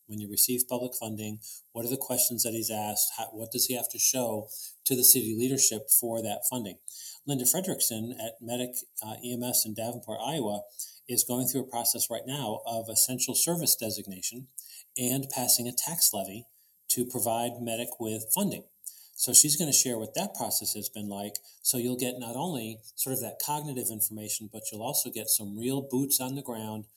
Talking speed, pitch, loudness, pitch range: 195 wpm, 120 Hz, -27 LUFS, 110-125 Hz